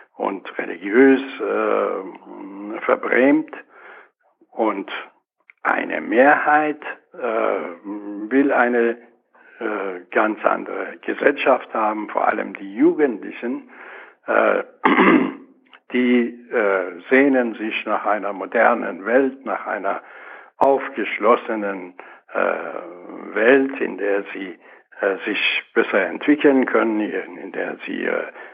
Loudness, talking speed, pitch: -20 LUFS, 95 wpm, 135 Hz